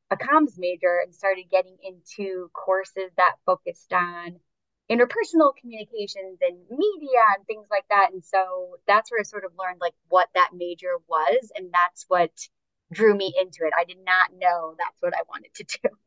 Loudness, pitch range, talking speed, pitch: -23 LUFS, 180-230 Hz, 185 wpm, 190 Hz